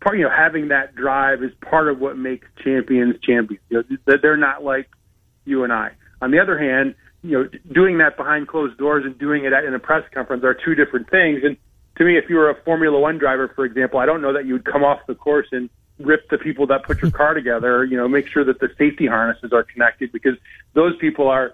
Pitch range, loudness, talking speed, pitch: 130-150 Hz, -18 LUFS, 250 wpm, 140 Hz